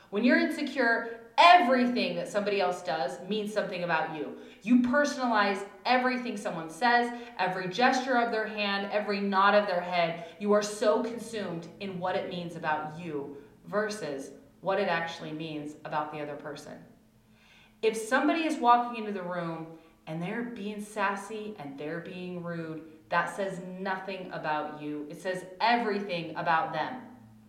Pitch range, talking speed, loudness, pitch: 165-220 Hz, 155 wpm, -29 LUFS, 190 Hz